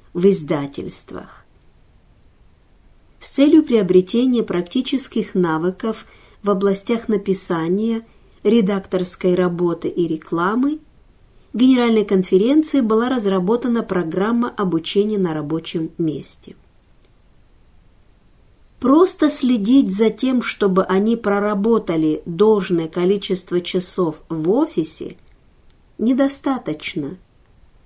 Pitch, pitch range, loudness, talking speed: 200 Hz, 175-235 Hz, -18 LUFS, 80 wpm